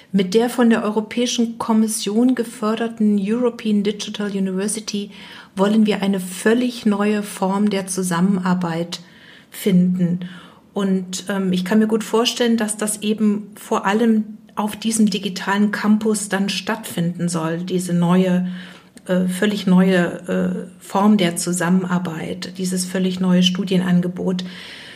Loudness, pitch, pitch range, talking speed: -19 LUFS, 200 Hz, 185-215 Hz, 125 wpm